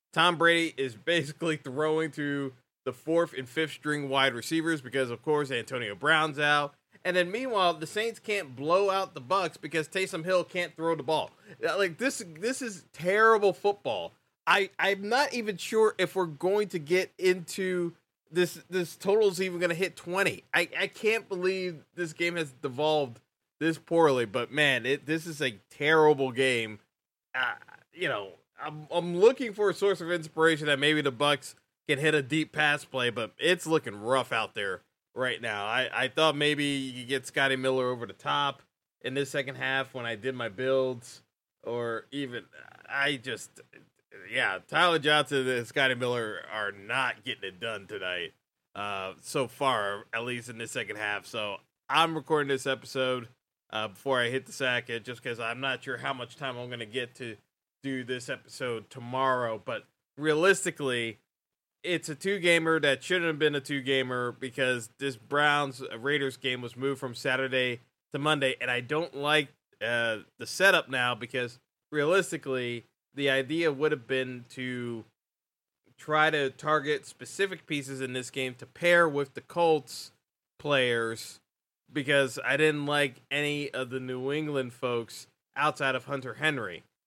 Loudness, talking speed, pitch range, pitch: -29 LUFS, 170 wpm, 130-165 Hz, 145 Hz